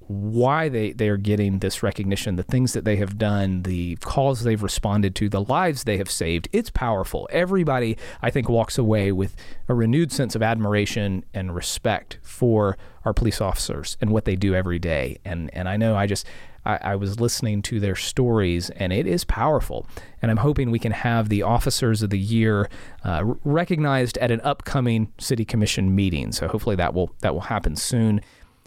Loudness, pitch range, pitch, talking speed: -23 LUFS, 95-120 Hz, 105 Hz, 195 wpm